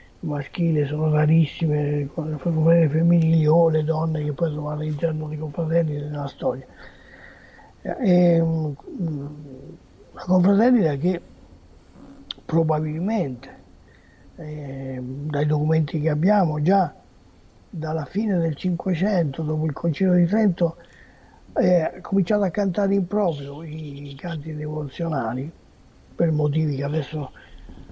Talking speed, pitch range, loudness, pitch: 115 wpm, 145-170 Hz, -23 LUFS, 155 Hz